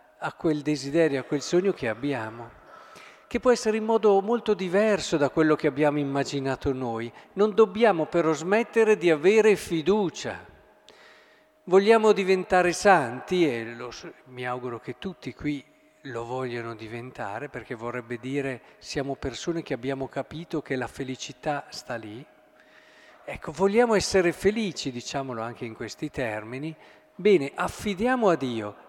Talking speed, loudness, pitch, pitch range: 140 wpm, -25 LUFS, 150 Hz, 125-190 Hz